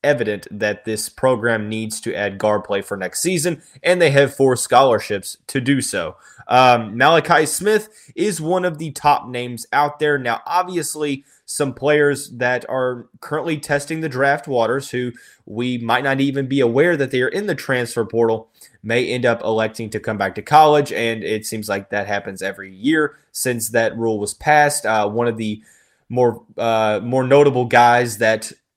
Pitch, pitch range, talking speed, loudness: 125 Hz, 110-145 Hz, 185 wpm, -18 LUFS